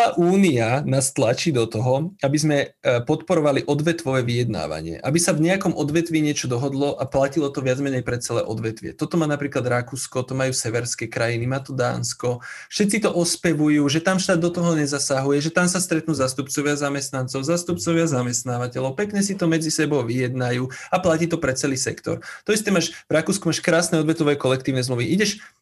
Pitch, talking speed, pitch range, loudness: 145 Hz, 180 wpm, 130-170 Hz, -22 LUFS